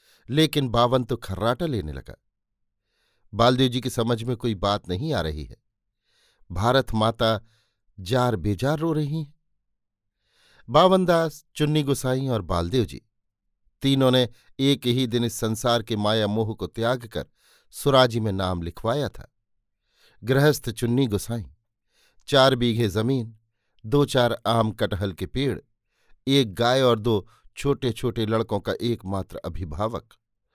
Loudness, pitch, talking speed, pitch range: -24 LUFS, 115 Hz, 140 wpm, 105-130 Hz